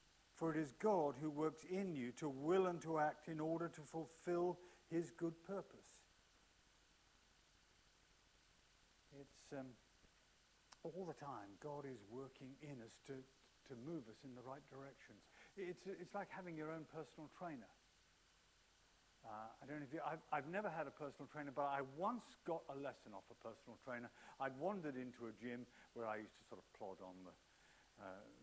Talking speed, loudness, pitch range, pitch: 175 wpm, -48 LUFS, 125-165 Hz, 150 Hz